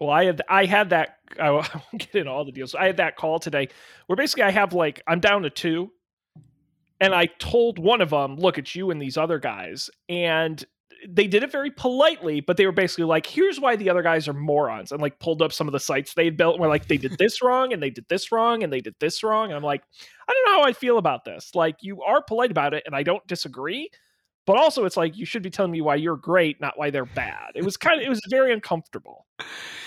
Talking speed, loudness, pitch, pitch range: 260 wpm, -22 LUFS, 170 Hz, 150-210 Hz